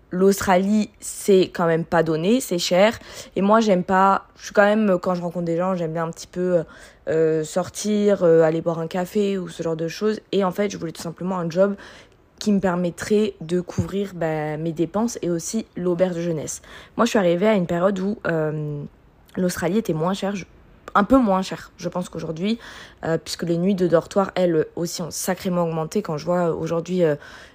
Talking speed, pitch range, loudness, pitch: 205 wpm, 165-195 Hz, -22 LUFS, 180 Hz